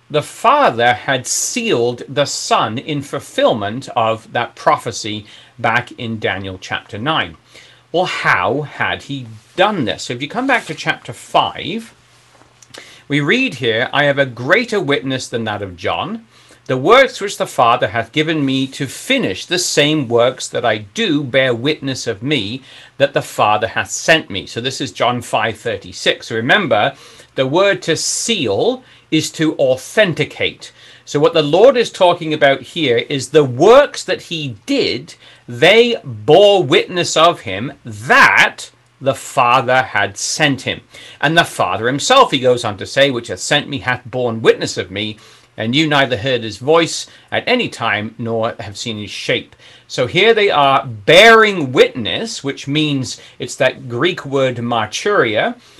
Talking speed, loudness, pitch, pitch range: 165 wpm, -15 LUFS, 135 Hz, 115-155 Hz